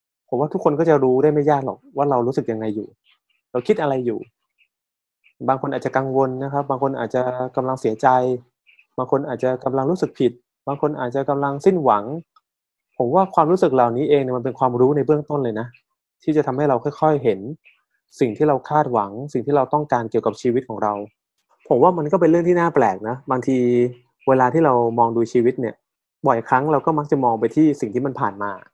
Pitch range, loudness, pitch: 120-150 Hz, -20 LUFS, 130 Hz